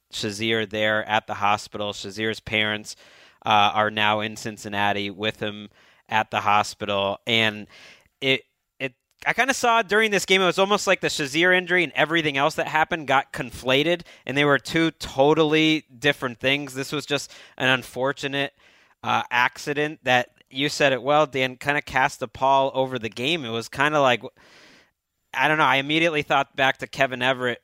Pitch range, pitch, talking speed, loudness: 110-150 Hz, 135 Hz, 180 wpm, -22 LUFS